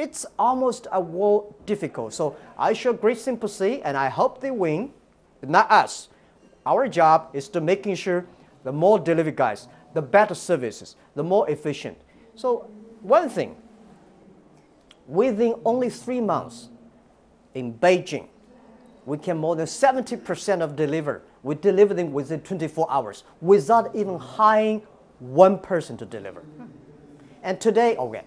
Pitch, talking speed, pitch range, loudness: 190 Hz, 140 wpm, 155-225 Hz, -23 LUFS